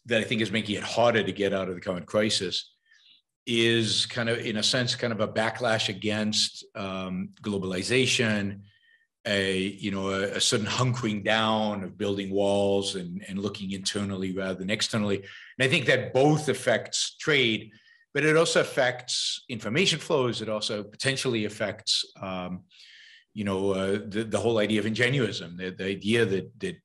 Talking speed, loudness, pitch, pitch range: 170 wpm, -26 LUFS, 105 Hz, 100-120 Hz